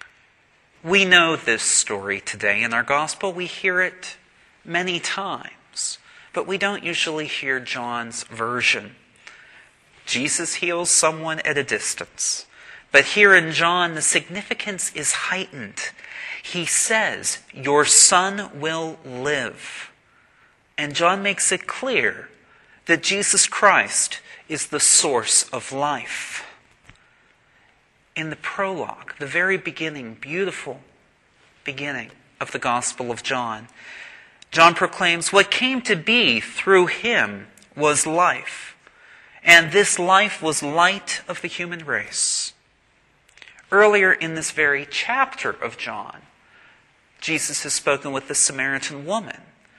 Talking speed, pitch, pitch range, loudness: 120 wpm, 165 Hz, 145-190 Hz, -19 LUFS